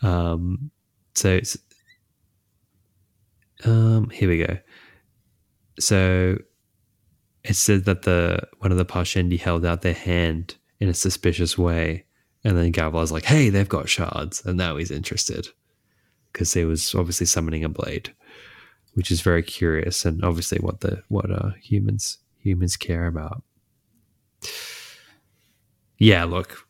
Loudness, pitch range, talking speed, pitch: -22 LUFS, 85-105 Hz, 135 wpm, 95 Hz